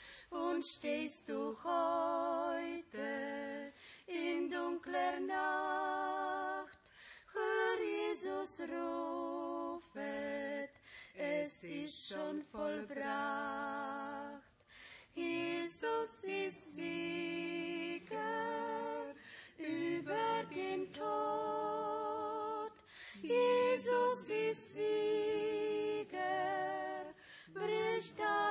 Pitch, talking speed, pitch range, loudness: 335 Hz, 55 wpm, 280-395 Hz, -39 LUFS